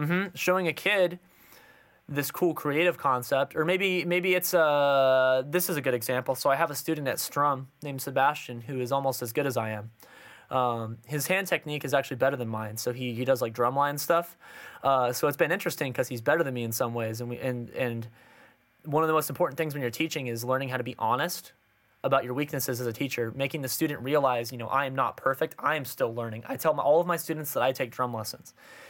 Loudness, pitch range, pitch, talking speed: -28 LUFS, 125-155 Hz, 135 Hz, 240 wpm